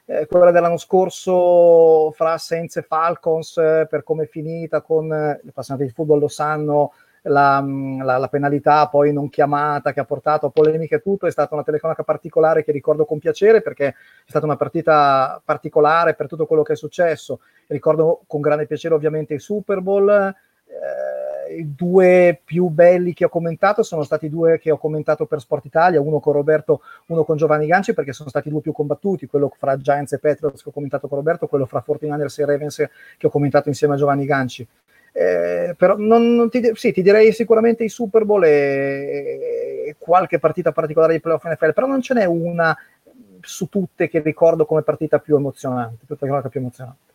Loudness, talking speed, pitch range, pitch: -18 LUFS, 195 wpm, 145-175 Hz, 155 Hz